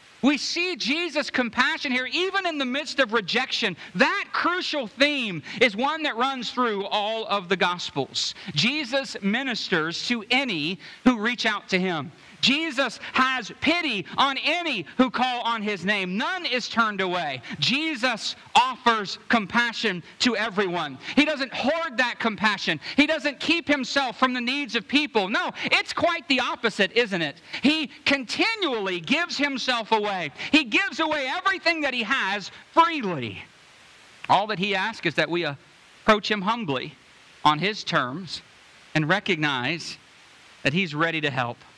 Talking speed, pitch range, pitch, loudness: 150 wpm, 195-280 Hz, 240 Hz, -24 LUFS